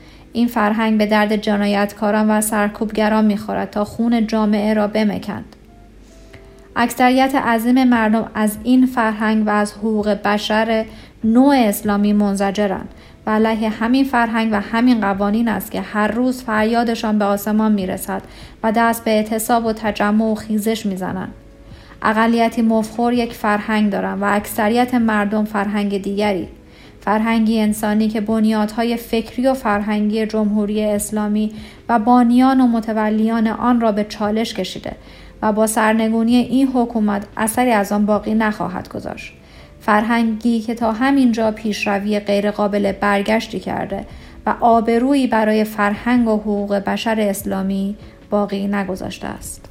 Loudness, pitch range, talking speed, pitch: -17 LUFS, 210-230 Hz, 135 wpm, 215 Hz